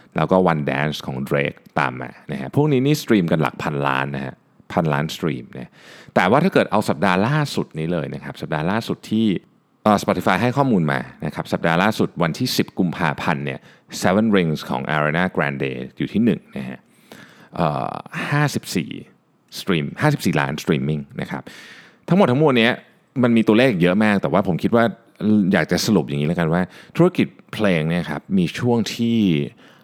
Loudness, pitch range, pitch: -20 LUFS, 75-120 Hz, 95 Hz